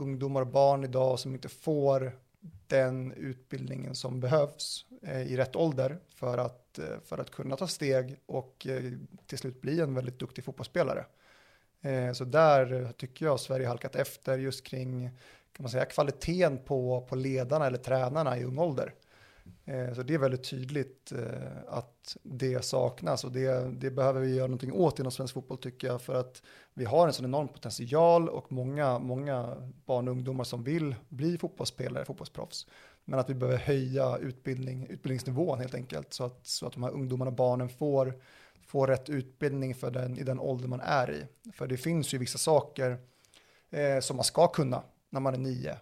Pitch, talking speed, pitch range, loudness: 130 Hz, 175 wpm, 125-140 Hz, -32 LUFS